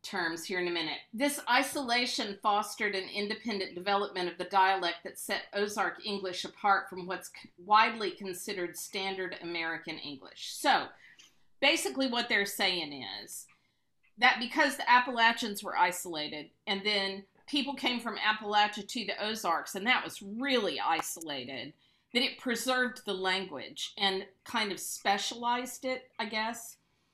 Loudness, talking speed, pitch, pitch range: -31 LUFS, 140 wpm, 205 Hz, 185-240 Hz